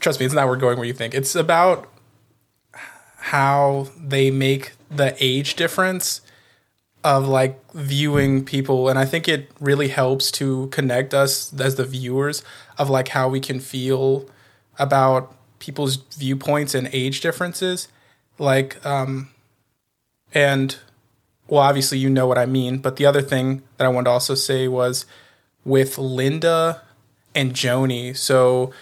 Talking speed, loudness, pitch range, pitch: 150 wpm, -20 LUFS, 130-140 Hz, 135 Hz